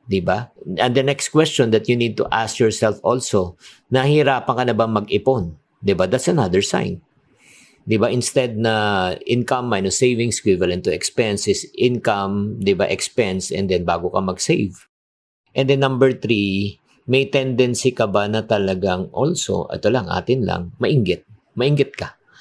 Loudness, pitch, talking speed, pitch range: -19 LUFS, 115 Hz, 150 wpm, 100-130 Hz